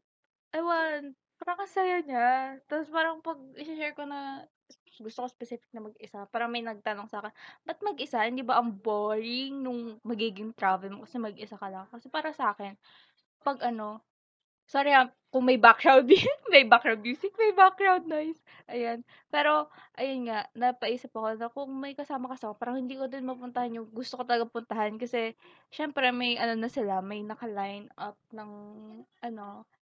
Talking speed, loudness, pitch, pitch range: 170 wpm, -28 LUFS, 245 Hz, 220-280 Hz